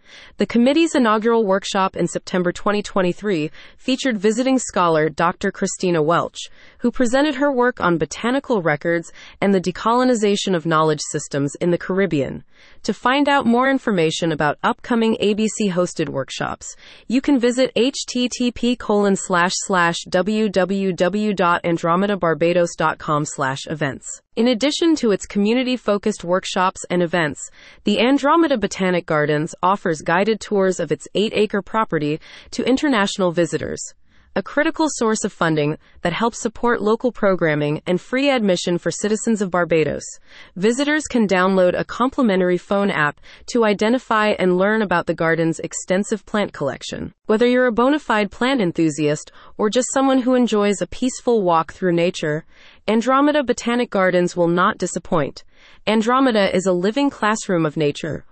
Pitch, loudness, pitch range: 200 Hz, -19 LUFS, 175-240 Hz